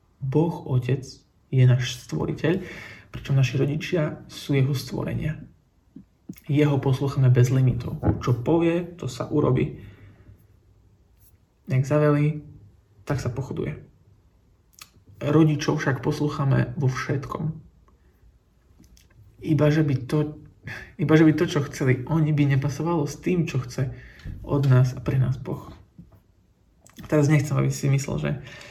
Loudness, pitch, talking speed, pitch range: -24 LUFS, 135 Hz, 115 wpm, 120-150 Hz